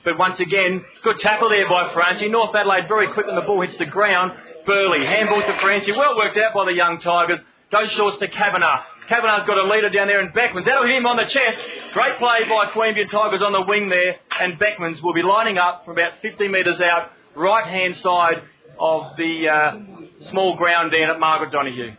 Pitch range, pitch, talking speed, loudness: 175-210 Hz, 195 Hz, 215 wpm, -18 LUFS